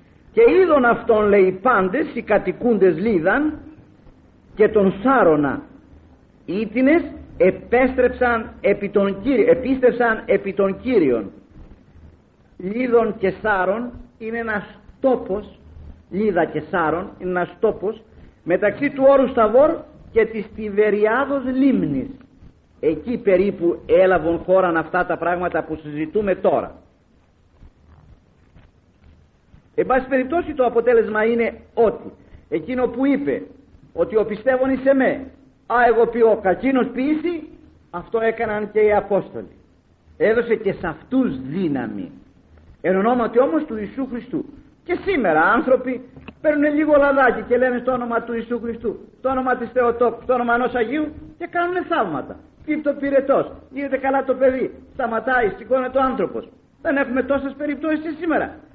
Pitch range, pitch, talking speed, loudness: 200-270 Hz, 235 Hz, 130 wpm, -19 LUFS